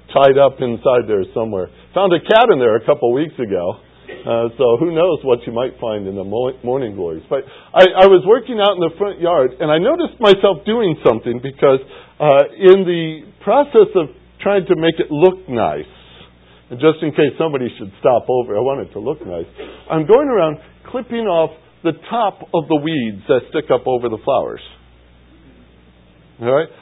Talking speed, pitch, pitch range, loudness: 195 wpm, 155 Hz, 120-190 Hz, -15 LUFS